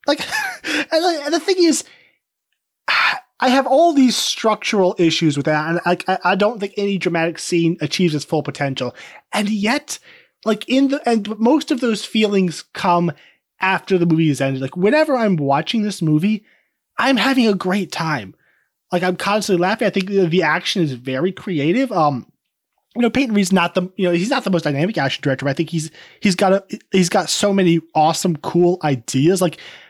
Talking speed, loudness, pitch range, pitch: 190 wpm, -18 LUFS, 165-220 Hz, 185 Hz